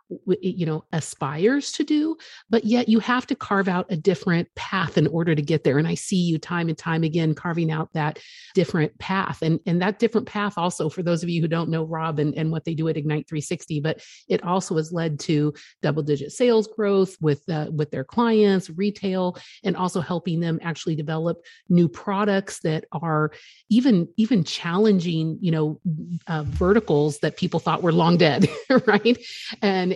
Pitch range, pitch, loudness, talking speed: 160-195 Hz, 170 Hz, -23 LUFS, 190 wpm